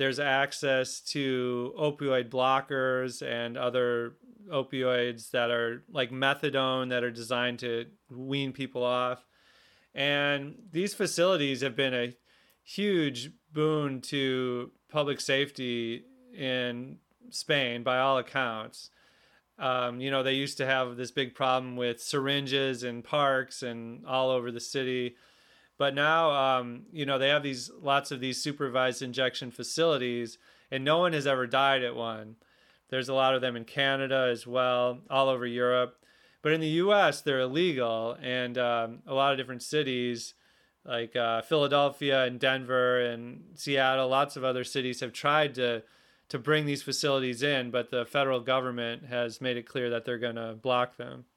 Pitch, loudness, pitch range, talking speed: 130 Hz, -29 LUFS, 125-140 Hz, 155 wpm